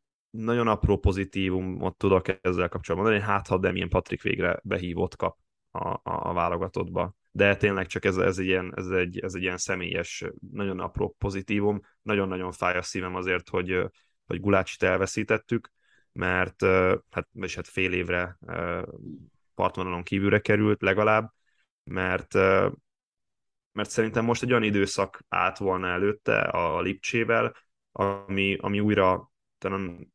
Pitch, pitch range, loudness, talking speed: 95 Hz, 90-105 Hz, -27 LUFS, 135 wpm